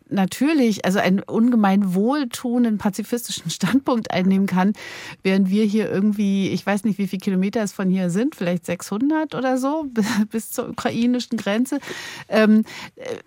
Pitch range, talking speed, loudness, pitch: 195-245 Hz, 145 wpm, -21 LUFS, 215 Hz